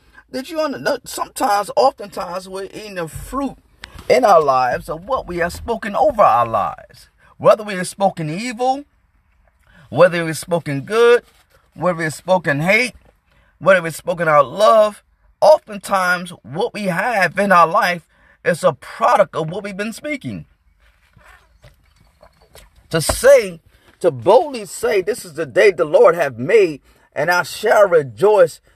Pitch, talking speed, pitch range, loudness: 205 Hz, 150 wpm, 180-265 Hz, -16 LUFS